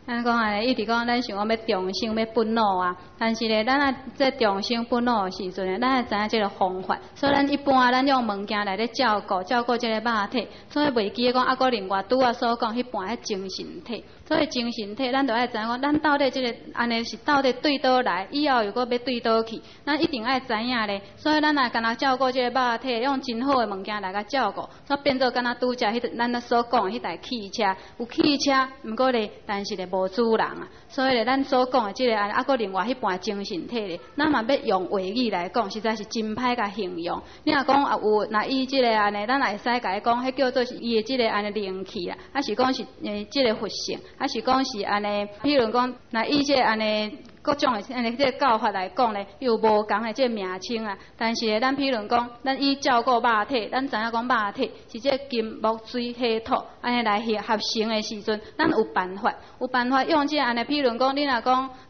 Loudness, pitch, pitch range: -24 LUFS, 240 Hz, 215-260 Hz